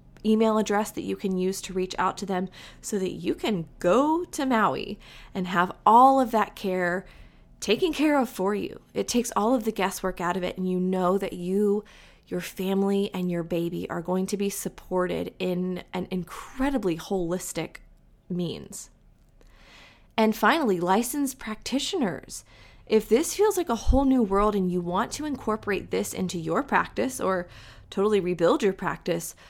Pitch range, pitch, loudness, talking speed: 180-220 Hz, 195 Hz, -26 LUFS, 170 wpm